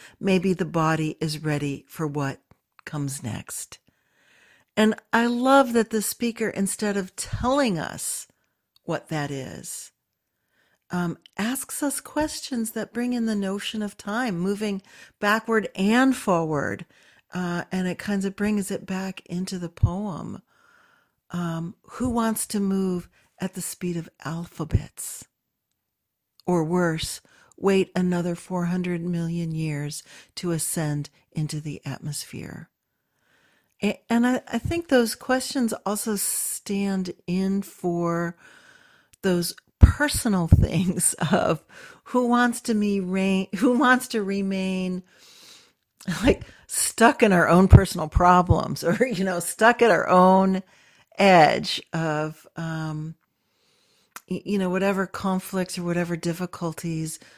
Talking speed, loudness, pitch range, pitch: 120 wpm, -24 LUFS, 170-220 Hz, 190 Hz